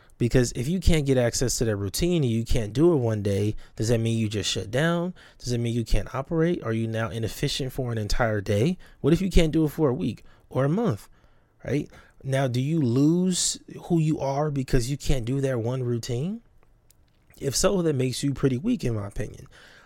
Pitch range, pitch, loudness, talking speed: 115-155 Hz, 130 Hz, -25 LUFS, 225 wpm